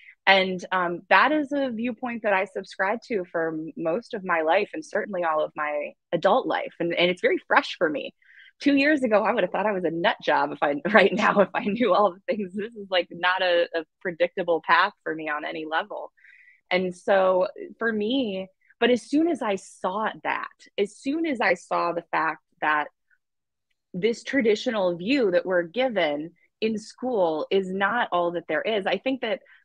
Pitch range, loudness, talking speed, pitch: 175-245 Hz, -24 LUFS, 200 wpm, 195 Hz